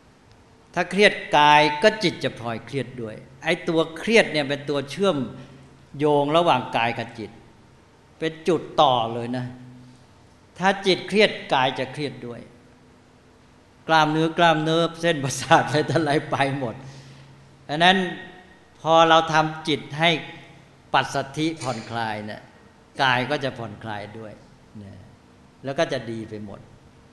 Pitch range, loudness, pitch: 115-160 Hz, -22 LUFS, 135 Hz